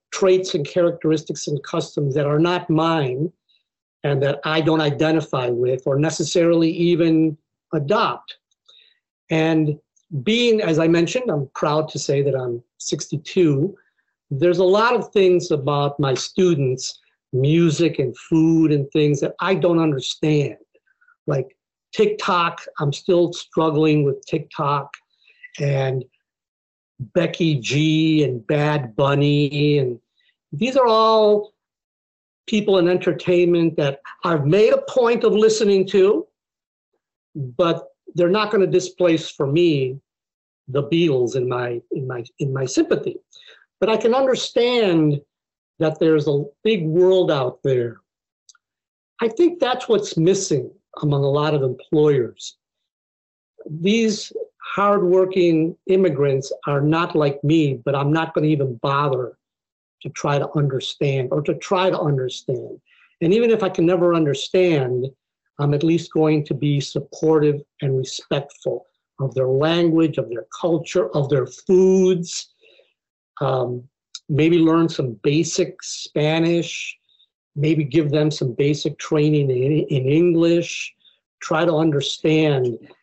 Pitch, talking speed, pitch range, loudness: 160 Hz, 130 wpm, 145-180 Hz, -19 LUFS